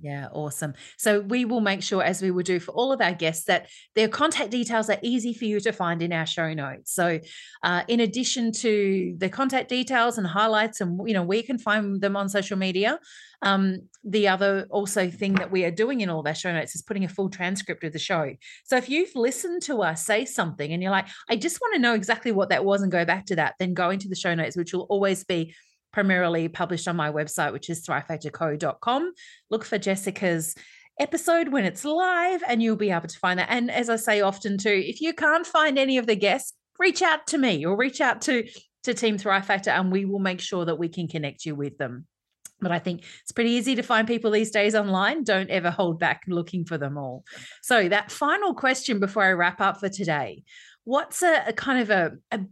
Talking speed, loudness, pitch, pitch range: 235 wpm, -25 LUFS, 200 Hz, 175-235 Hz